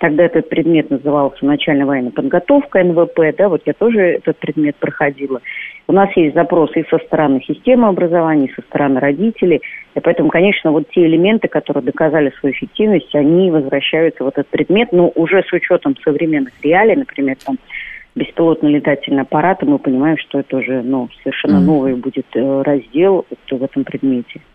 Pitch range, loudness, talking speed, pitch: 140-175 Hz, -14 LUFS, 165 wpm, 155 Hz